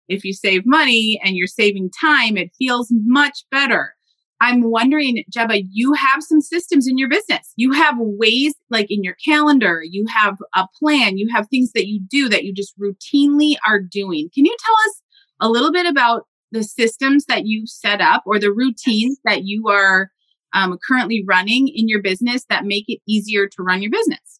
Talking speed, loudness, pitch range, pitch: 195 wpm, -16 LUFS, 205-285 Hz, 230 Hz